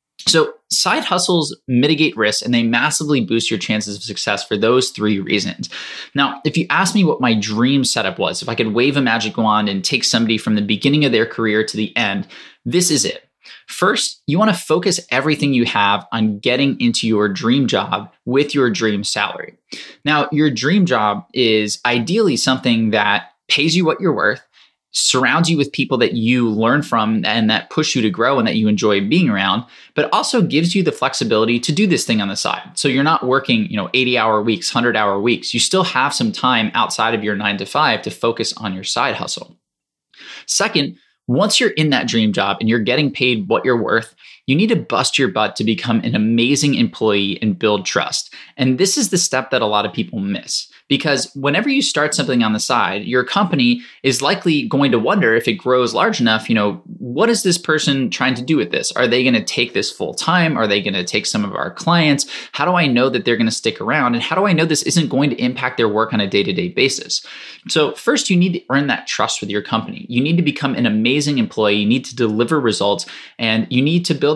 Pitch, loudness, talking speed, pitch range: 125 Hz, -16 LUFS, 230 wpm, 110-155 Hz